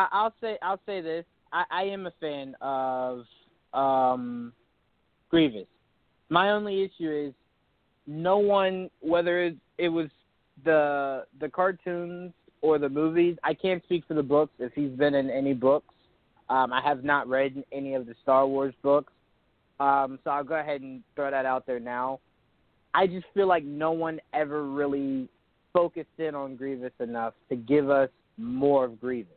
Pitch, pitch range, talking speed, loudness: 145 Hz, 130-170 Hz, 170 wpm, -27 LUFS